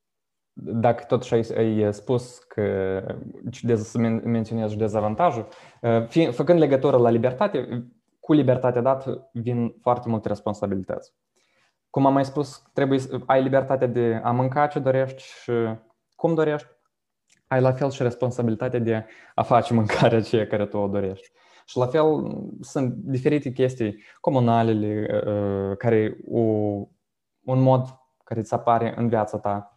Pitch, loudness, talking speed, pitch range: 120 Hz, -23 LUFS, 140 wpm, 110-130 Hz